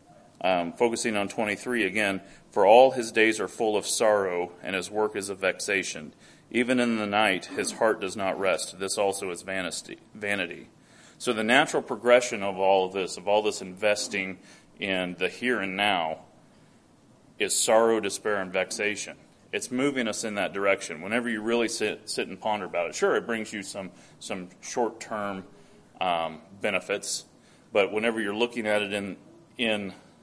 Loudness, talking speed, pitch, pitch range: -27 LUFS, 175 wpm, 105 Hz, 95-115 Hz